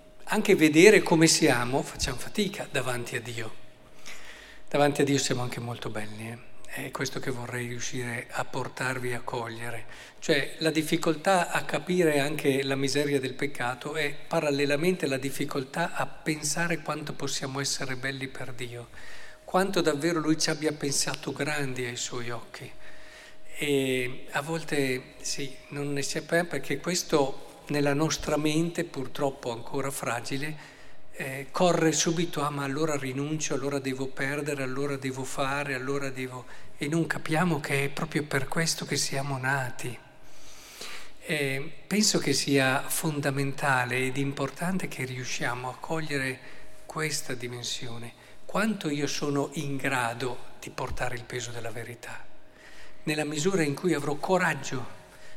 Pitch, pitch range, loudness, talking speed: 140 Hz, 130-155 Hz, -28 LUFS, 140 wpm